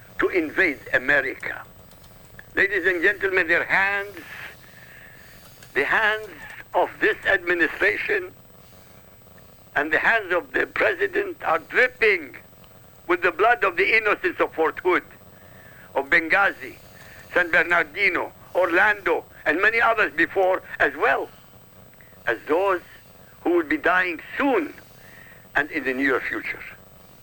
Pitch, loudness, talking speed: 360 Hz, -21 LUFS, 115 wpm